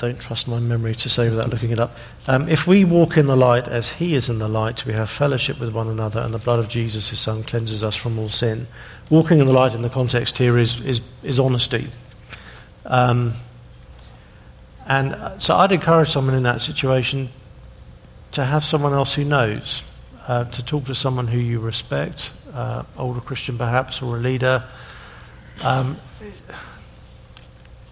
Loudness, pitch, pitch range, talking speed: -19 LUFS, 120 Hz, 115-135 Hz, 180 wpm